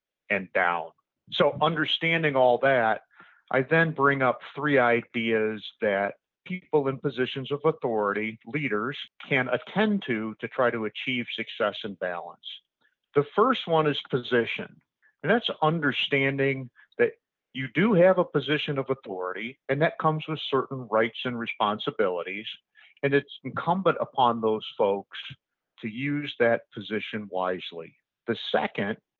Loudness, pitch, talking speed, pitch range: -26 LUFS, 135 Hz, 135 wpm, 115-150 Hz